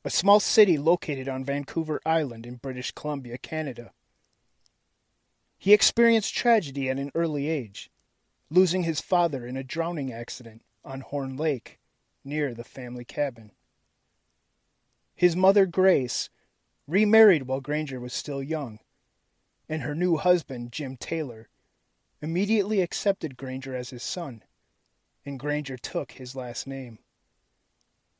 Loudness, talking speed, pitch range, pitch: -26 LUFS, 125 wpm, 125-170 Hz, 145 Hz